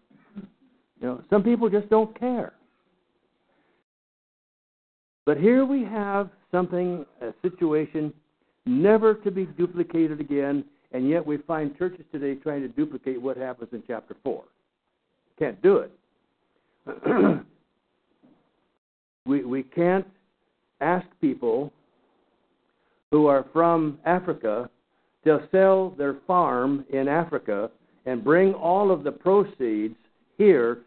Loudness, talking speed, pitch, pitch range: -24 LUFS, 115 wpm, 170 Hz, 140-200 Hz